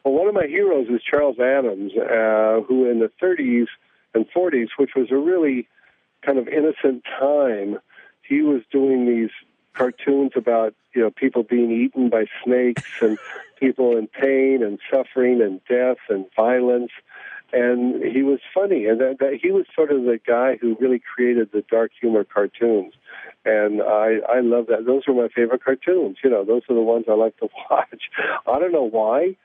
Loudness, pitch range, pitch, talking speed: -20 LUFS, 115-135 Hz, 125 Hz, 185 wpm